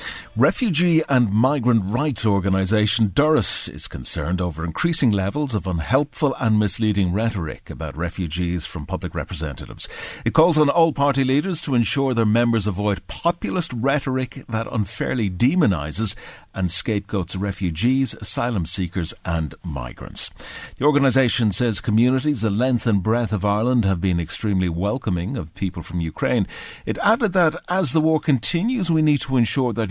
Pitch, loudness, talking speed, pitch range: 110 Hz, -21 LUFS, 150 wpm, 95-135 Hz